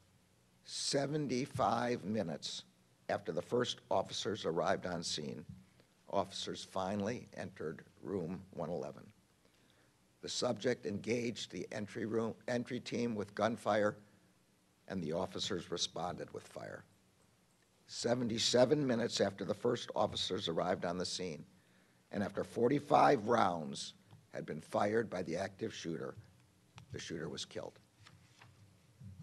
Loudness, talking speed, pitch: -37 LUFS, 115 wpm, 105 Hz